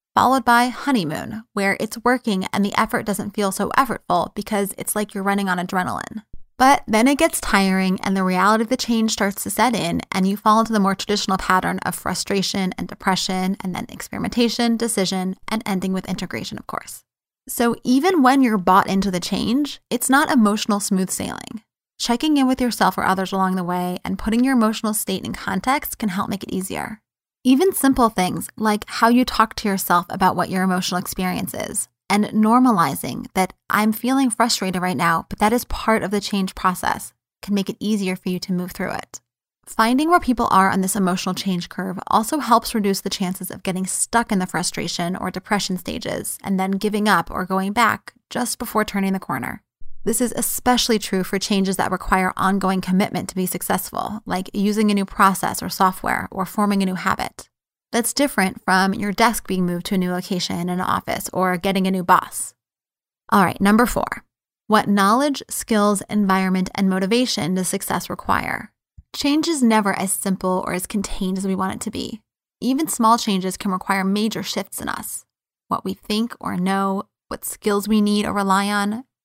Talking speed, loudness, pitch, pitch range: 195 wpm, -20 LUFS, 200 Hz, 190-230 Hz